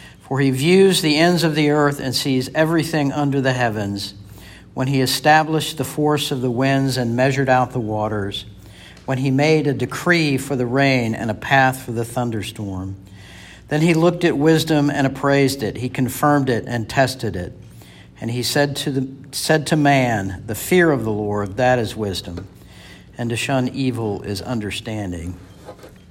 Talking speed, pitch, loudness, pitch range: 175 wpm, 130 Hz, -19 LUFS, 105-145 Hz